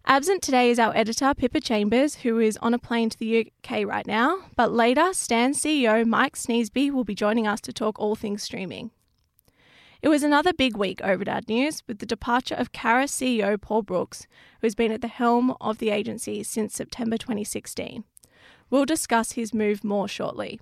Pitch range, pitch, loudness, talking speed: 220-255 Hz, 230 Hz, -24 LUFS, 195 wpm